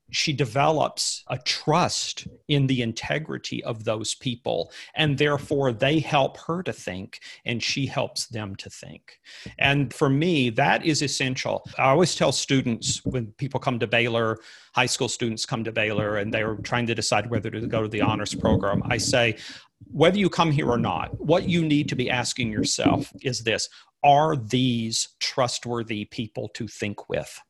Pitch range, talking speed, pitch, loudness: 115-140 Hz, 175 wpm, 125 Hz, -24 LUFS